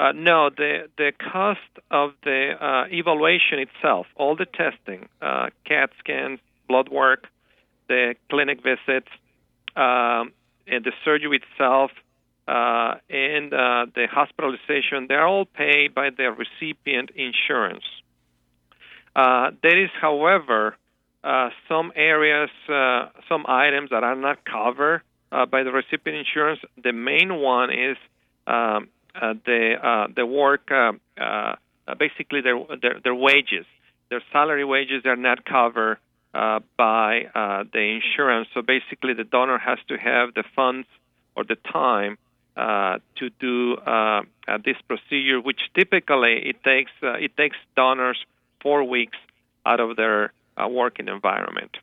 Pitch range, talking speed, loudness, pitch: 115-145 Hz, 140 wpm, -21 LUFS, 130 Hz